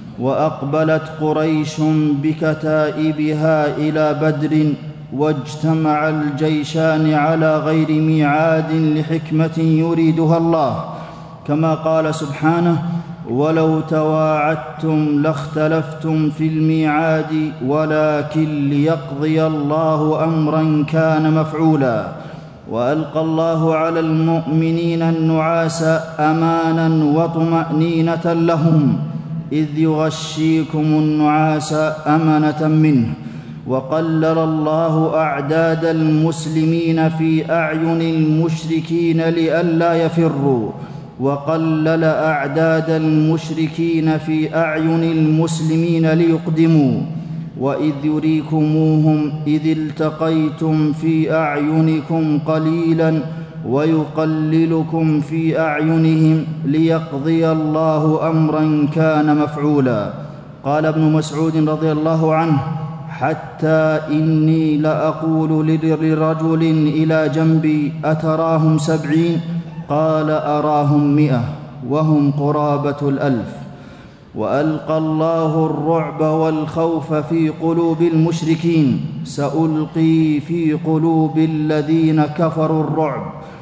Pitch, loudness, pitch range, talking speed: 155 Hz, -16 LUFS, 155-160 Hz, 75 wpm